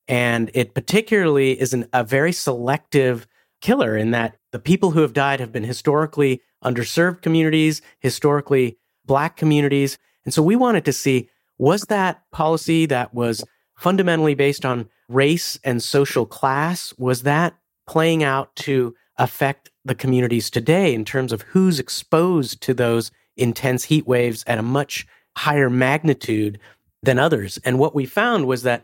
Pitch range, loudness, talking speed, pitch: 125-155 Hz, -20 LUFS, 155 wpm, 135 Hz